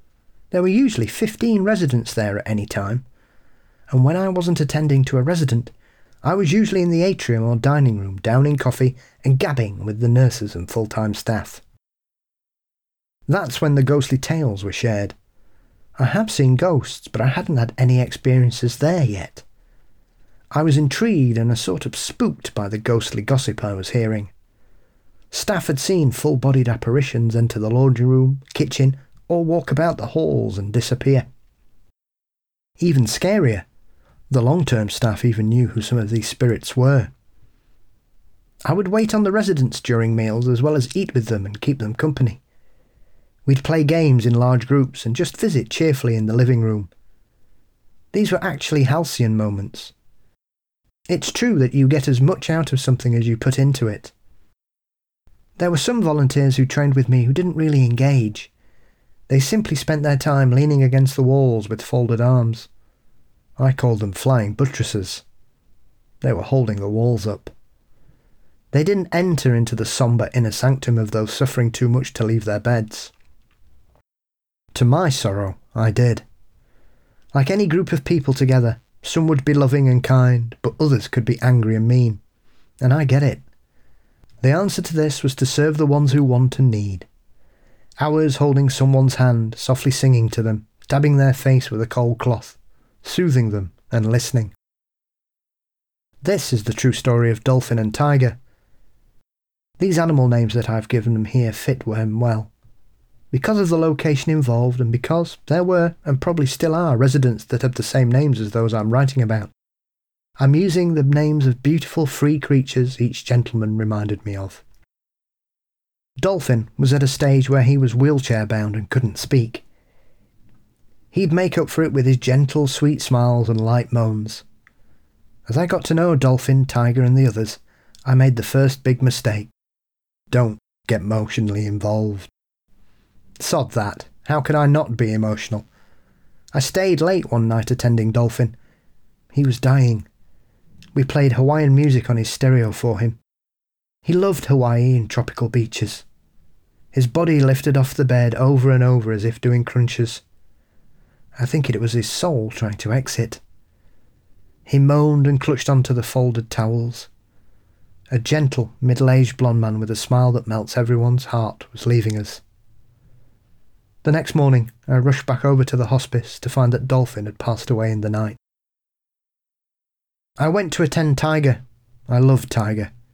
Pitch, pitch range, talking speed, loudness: 125 Hz, 115-140 Hz, 165 wpm, -19 LUFS